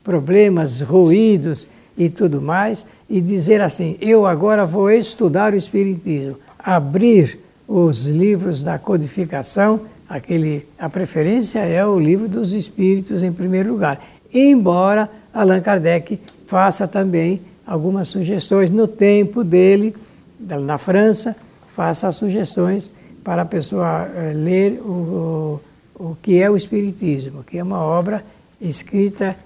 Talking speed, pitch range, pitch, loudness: 120 wpm, 170-205 Hz, 190 Hz, -17 LUFS